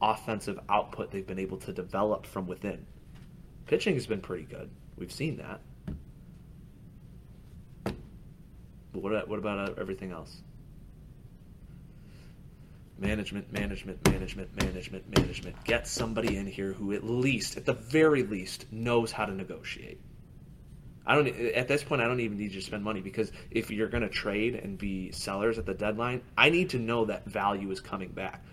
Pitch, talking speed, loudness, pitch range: 105 Hz, 165 wpm, -31 LUFS, 95-115 Hz